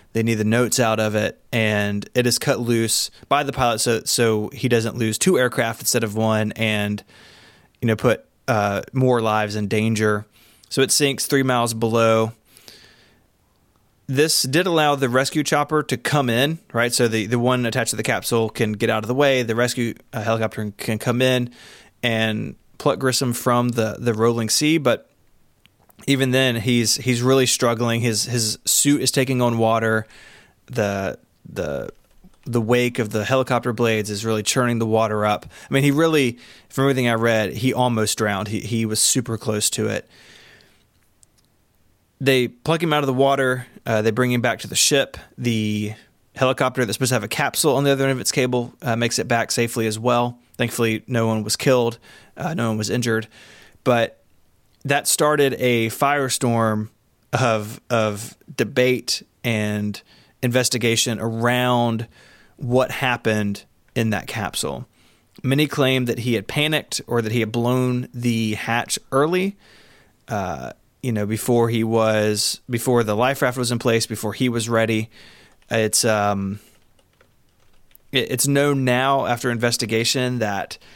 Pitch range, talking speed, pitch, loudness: 110-130 Hz, 170 wpm, 120 Hz, -20 LUFS